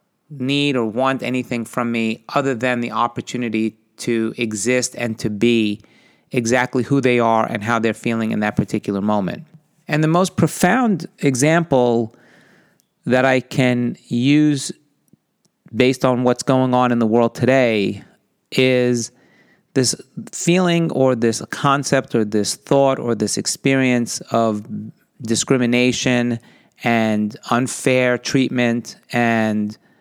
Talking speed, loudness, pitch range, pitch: 125 wpm, -18 LUFS, 115-135 Hz, 125 Hz